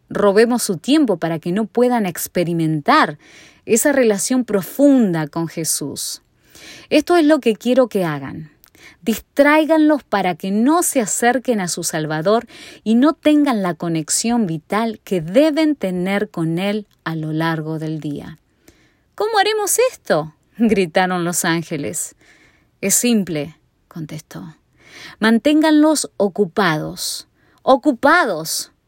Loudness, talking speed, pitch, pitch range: -17 LUFS, 120 wpm, 205 Hz, 170-260 Hz